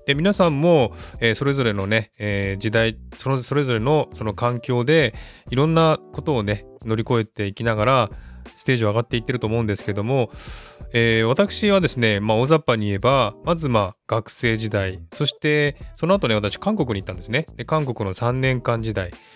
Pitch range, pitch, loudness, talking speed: 110-145 Hz, 120 Hz, -21 LUFS, 370 characters per minute